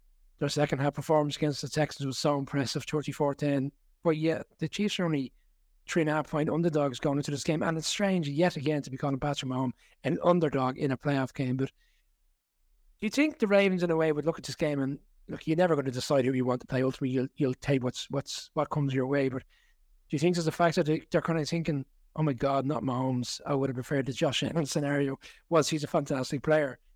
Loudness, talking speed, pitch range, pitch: -29 LUFS, 245 wpm, 135-160 Hz, 145 Hz